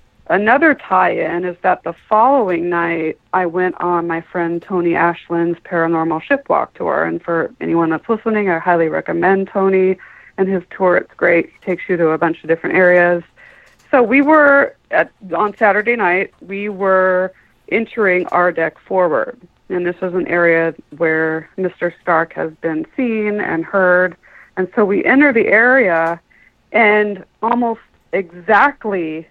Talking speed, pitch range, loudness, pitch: 155 wpm, 170-205 Hz, -15 LUFS, 180 Hz